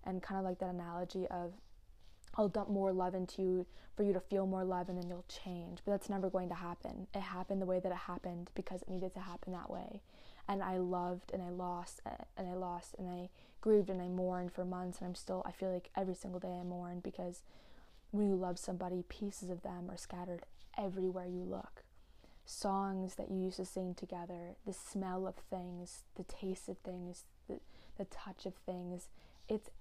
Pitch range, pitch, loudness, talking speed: 180-190 Hz, 185 Hz, -42 LUFS, 210 wpm